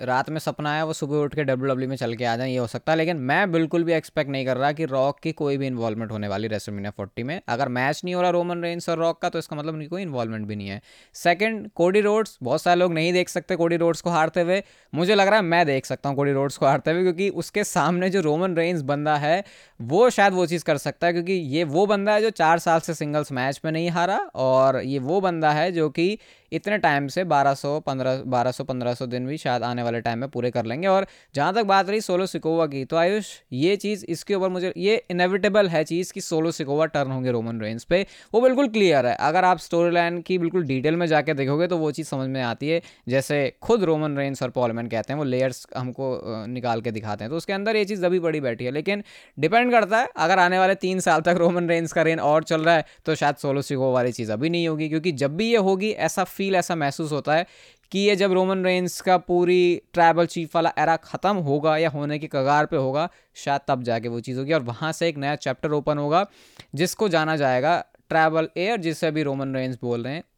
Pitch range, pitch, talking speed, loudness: 135-180 Hz, 160 Hz, 250 wpm, -23 LUFS